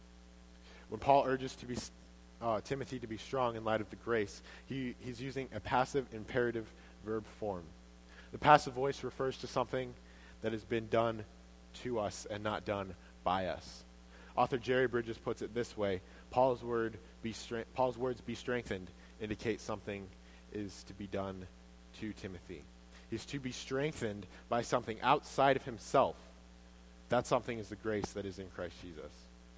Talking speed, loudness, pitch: 165 wpm, -37 LUFS, 105 Hz